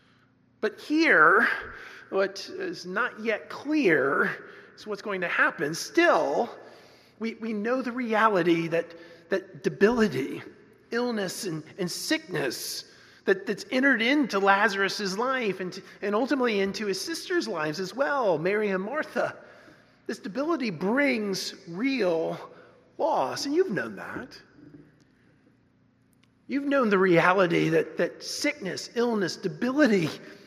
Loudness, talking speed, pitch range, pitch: -26 LUFS, 120 wpm, 190-275 Hz, 210 Hz